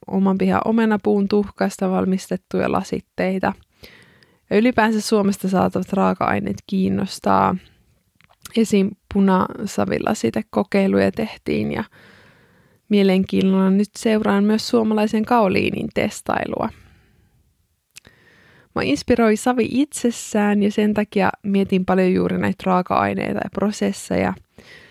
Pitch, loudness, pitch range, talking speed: 195 Hz, -20 LUFS, 140-215 Hz, 95 wpm